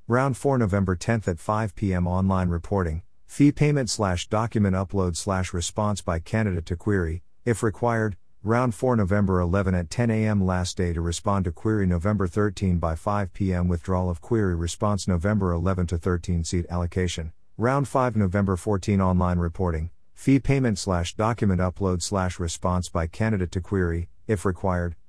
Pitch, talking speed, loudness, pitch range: 95 Hz, 165 wpm, -25 LUFS, 90-105 Hz